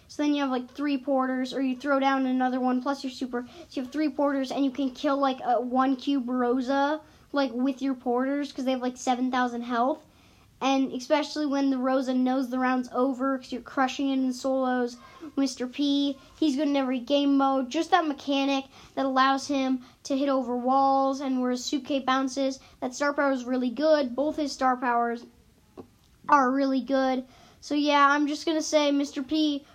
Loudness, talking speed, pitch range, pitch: -26 LUFS, 200 wpm, 255-285 Hz, 270 Hz